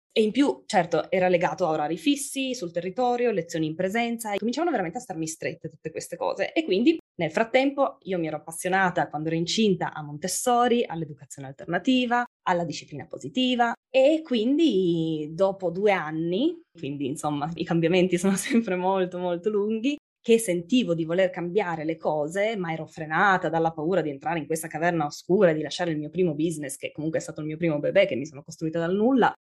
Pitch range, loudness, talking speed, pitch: 160-230 Hz, -25 LUFS, 190 wpm, 180 Hz